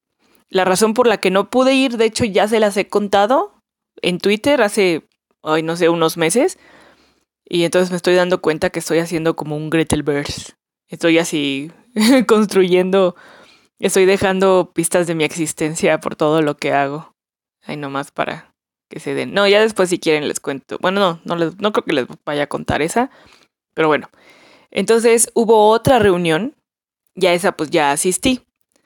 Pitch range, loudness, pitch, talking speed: 165-210 Hz, -16 LUFS, 185 Hz, 180 wpm